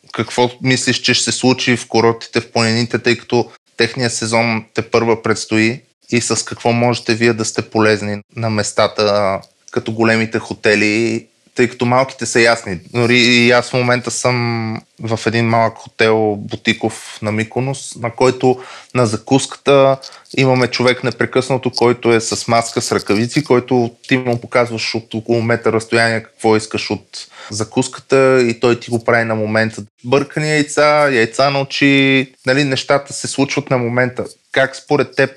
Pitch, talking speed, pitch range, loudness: 120 Hz, 160 wpm, 115-130 Hz, -15 LUFS